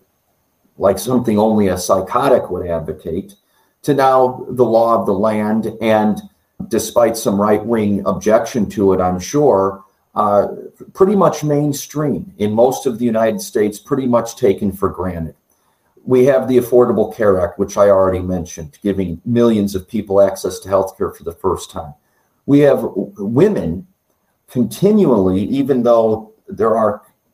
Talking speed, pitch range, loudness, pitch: 150 wpm, 95-125 Hz, -16 LUFS, 110 Hz